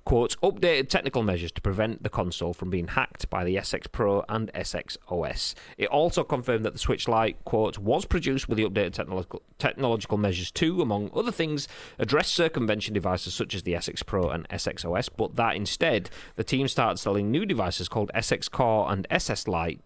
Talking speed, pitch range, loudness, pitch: 195 wpm, 95-130 Hz, -27 LUFS, 105 Hz